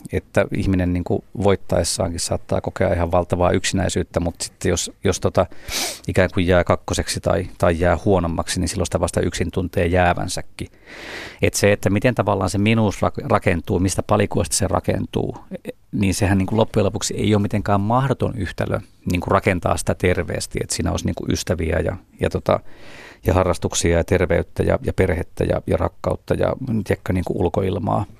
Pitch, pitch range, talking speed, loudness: 95 Hz, 90-105 Hz, 165 wpm, -20 LUFS